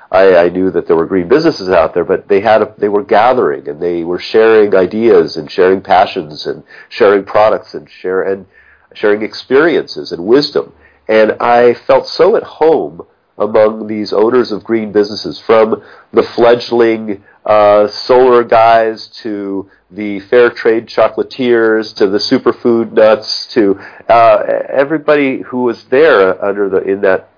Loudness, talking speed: -11 LUFS, 155 wpm